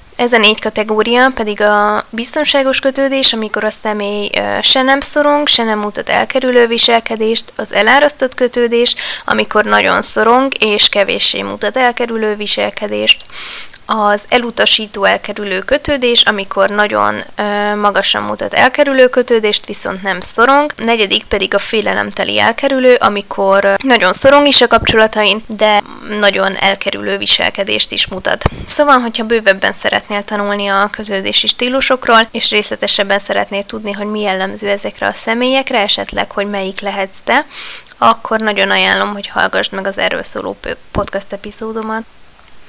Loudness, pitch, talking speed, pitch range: -11 LUFS, 215 Hz, 130 wpm, 205-245 Hz